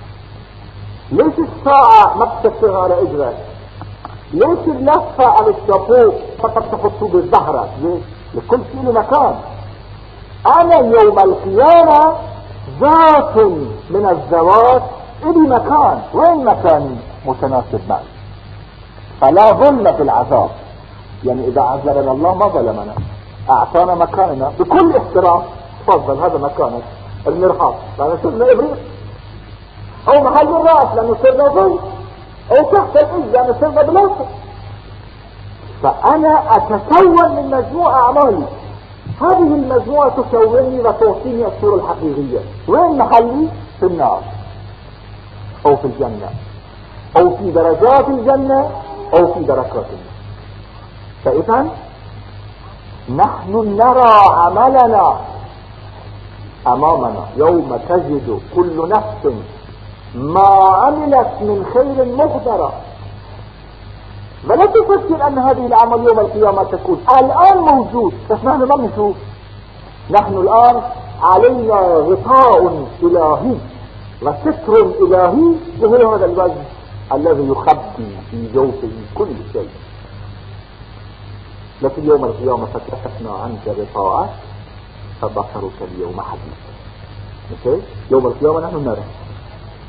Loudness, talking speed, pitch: -12 LUFS, 95 wpm, 155 Hz